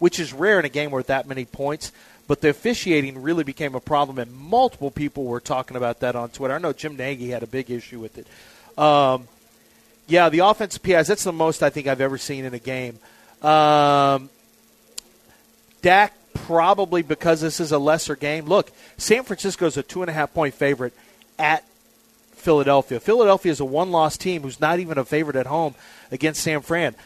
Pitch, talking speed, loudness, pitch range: 150 Hz, 195 wpm, -21 LUFS, 135-165 Hz